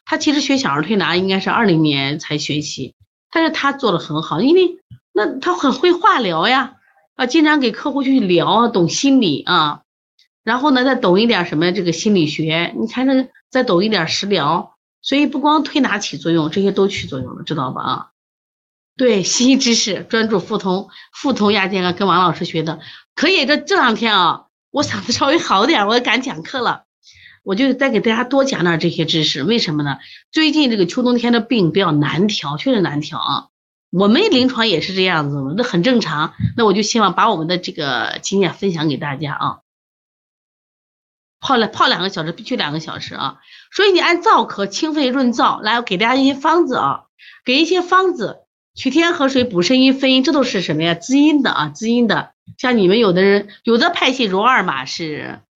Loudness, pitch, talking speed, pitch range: -16 LUFS, 220 Hz, 295 characters per minute, 170-270 Hz